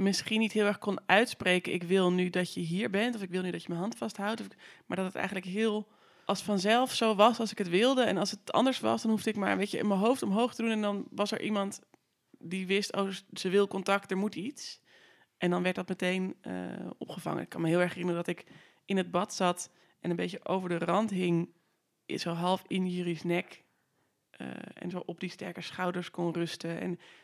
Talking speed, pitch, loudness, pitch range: 240 wpm, 190 Hz, -31 LUFS, 175-210 Hz